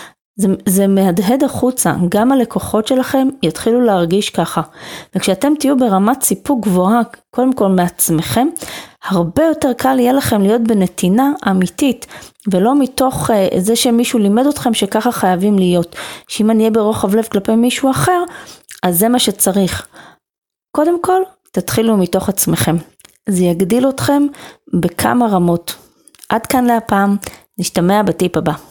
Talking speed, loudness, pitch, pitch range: 135 wpm, -14 LUFS, 220 Hz, 190-255 Hz